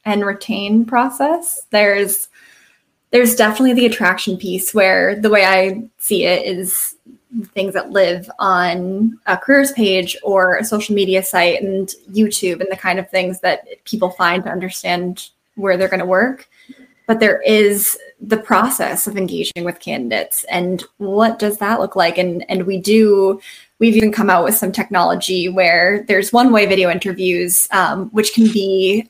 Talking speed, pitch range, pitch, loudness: 165 wpm, 185-220 Hz, 195 Hz, -15 LUFS